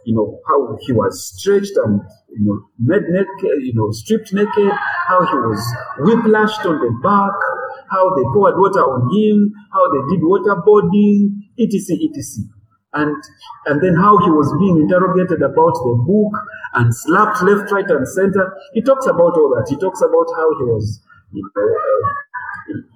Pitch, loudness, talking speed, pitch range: 195 Hz, -15 LUFS, 165 wpm, 140-215 Hz